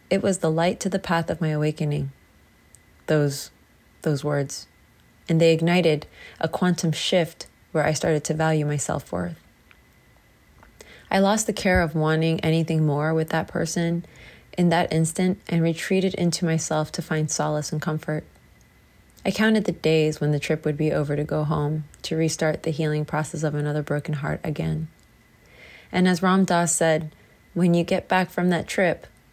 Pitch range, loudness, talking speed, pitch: 150-175 Hz, -23 LUFS, 170 wpm, 160 Hz